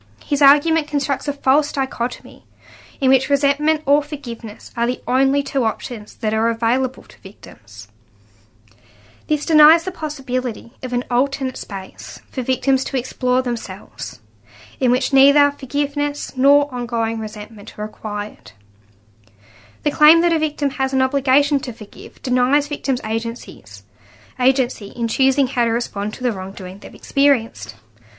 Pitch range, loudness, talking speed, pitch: 200-280 Hz, -19 LUFS, 145 wpm, 250 Hz